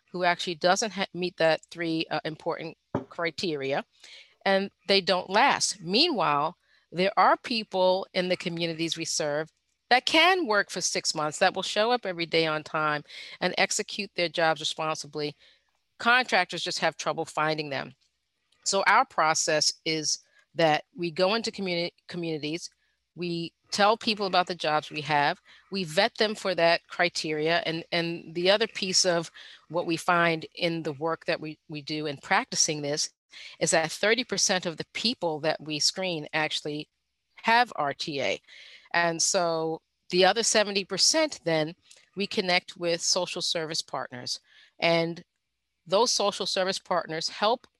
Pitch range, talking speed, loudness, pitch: 160-195 Hz, 150 wpm, -26 LUFS, 175 Hz